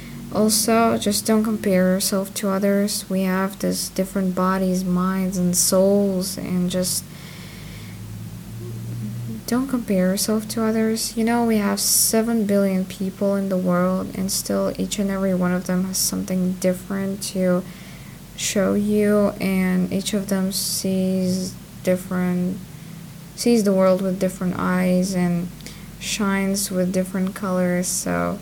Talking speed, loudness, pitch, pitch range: 135 wpm, -21 LUFS, 185 Hz, 180-200 Hz